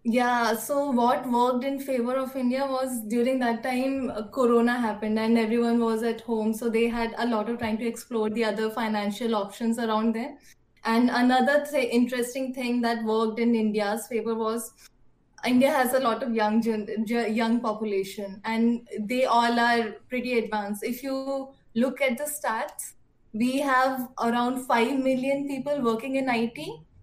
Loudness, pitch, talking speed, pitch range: -26 LUFS, 235 Hz, 165 wpm, 225-255 Hz